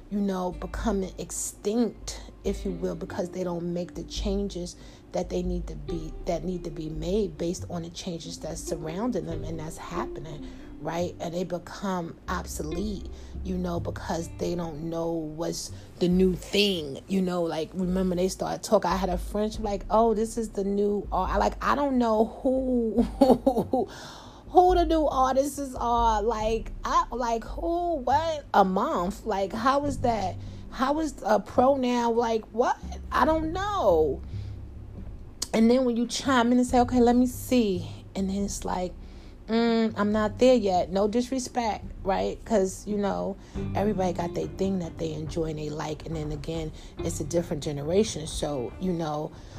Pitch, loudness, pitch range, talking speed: 195 Hz, -27 LUFS, 170-235 Hz, 175 wpm